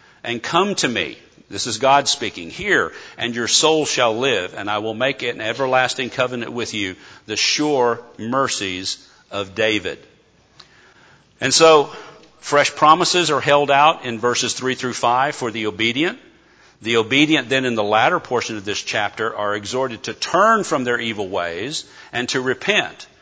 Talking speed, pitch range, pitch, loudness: 170 wpm, 110-140 Hz, 120 Hz, -18 LUFS